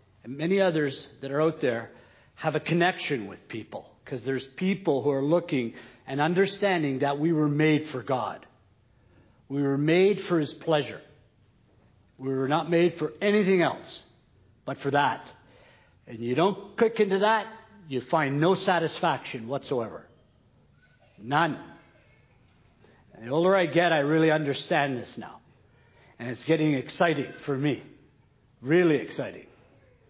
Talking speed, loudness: 145 wpm, -26 LUFS